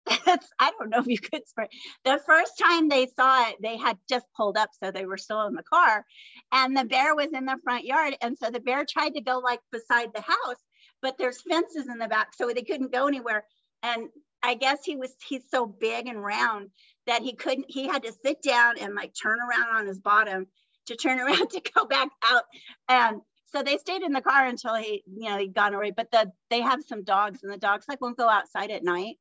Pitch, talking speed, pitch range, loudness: 245 Hz, 240 wpm, 220-280 Hz, -26 LUFS